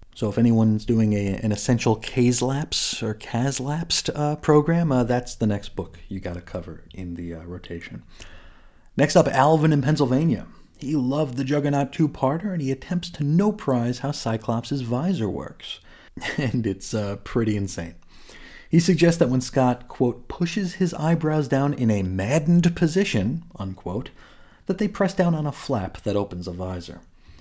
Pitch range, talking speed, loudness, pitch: 100-155 Hz, 175 wpm, -23 LUFS, 125 Hz